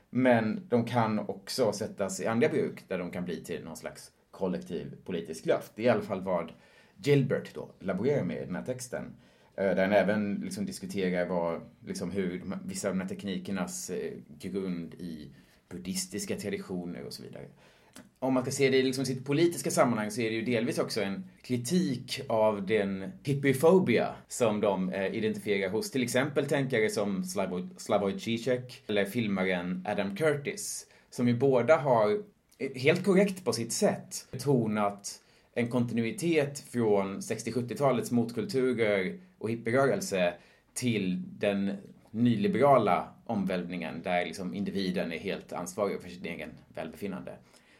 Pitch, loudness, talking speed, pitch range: 115 Hz, -30 LUFS, 150 wpm, 95-135 Hz